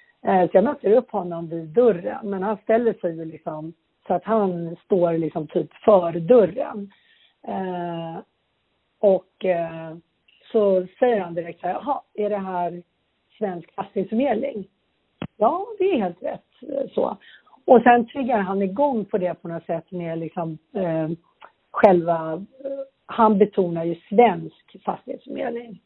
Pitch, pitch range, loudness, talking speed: 190 Hz, 170-225 Hz, -22 LUFS, 140 wpm